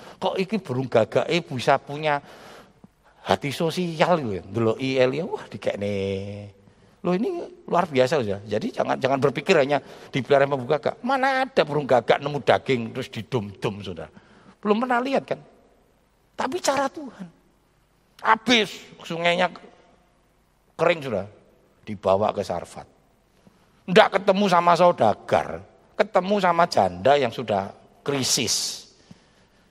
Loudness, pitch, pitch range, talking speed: -23 LUFS, 170 Hz, 125-205 Hz, 115 wpm